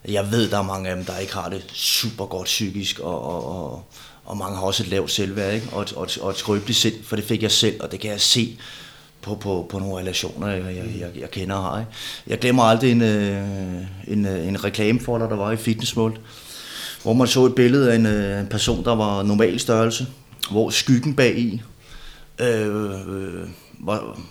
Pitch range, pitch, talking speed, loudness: 95-115 Hz, 105 Hz, 210 wpm, -21 LUFS